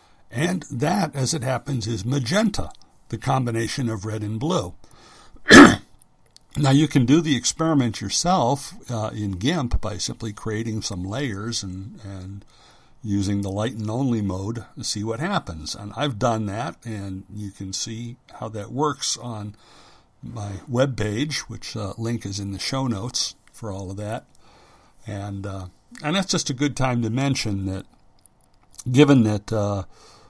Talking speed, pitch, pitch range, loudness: 160 wpm, 115 Hz, 100-135 Hz, -22 LUFS